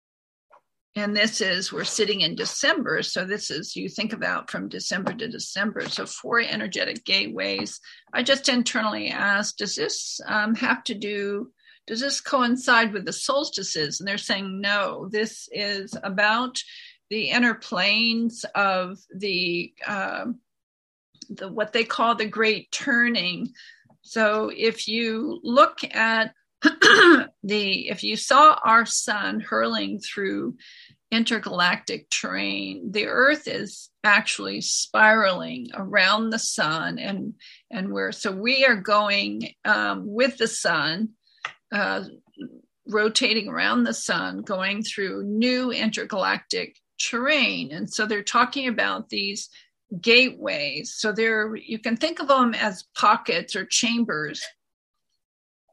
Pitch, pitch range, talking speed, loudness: 225 Hz, 205-245 Hz, 130 wpm, -22 LUFS